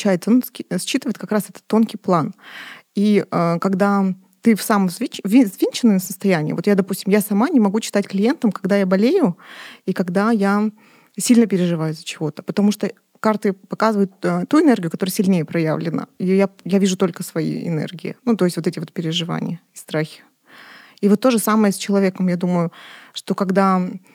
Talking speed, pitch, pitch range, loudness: 170 wpm, 200 Hz, 185-215 Hz, -19 LUFS